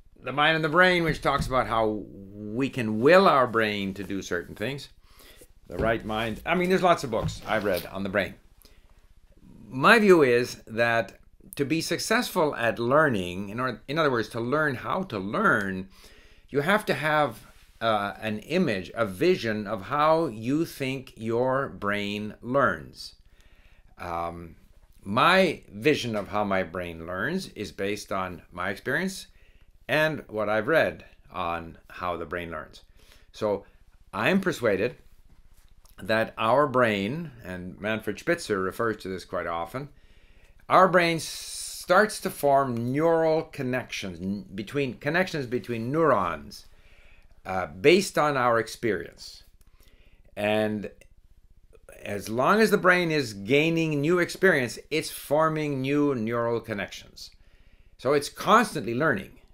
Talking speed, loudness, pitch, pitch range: 140 wpm, -25 LUFS, 110 Hz, 95-150 Hz